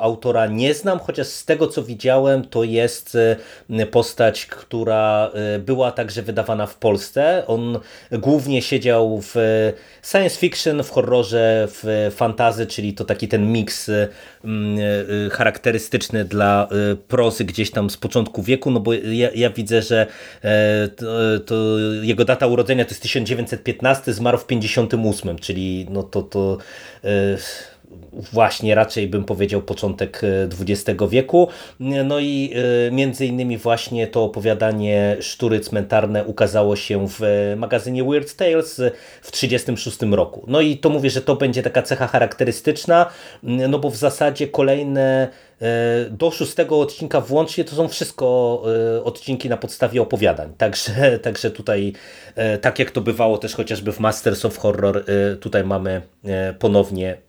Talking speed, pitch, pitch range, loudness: 135 wpm, 115 Hz, 105-130 Hz, -19 LUFS